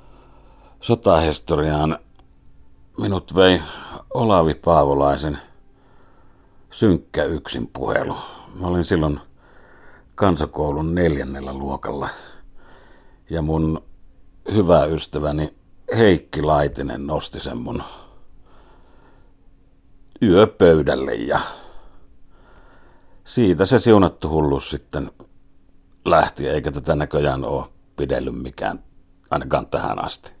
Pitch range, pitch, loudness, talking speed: 70-90 Hz, 75 Hz, -20 LUFS, 80 wpm